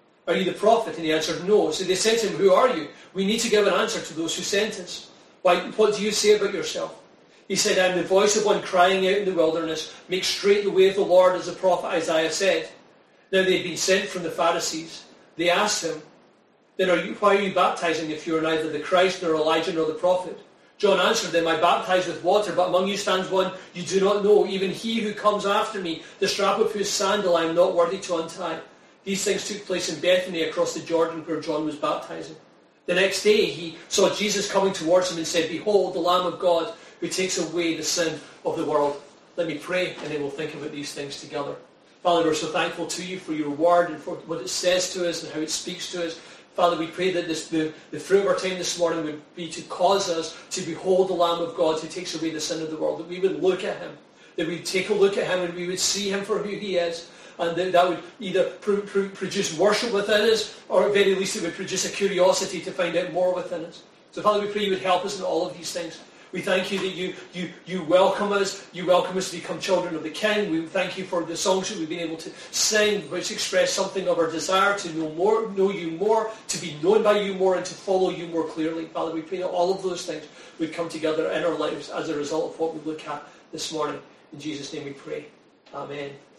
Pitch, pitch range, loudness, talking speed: 180 Hz, 165-195 Hz, -24 LUFS, 255 wpm